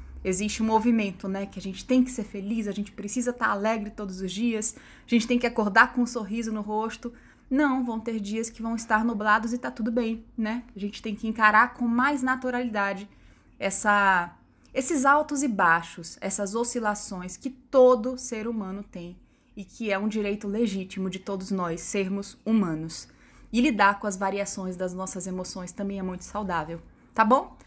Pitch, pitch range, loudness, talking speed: 215 Hz, 195-235 Hz, -26 LUFS, 190 wpm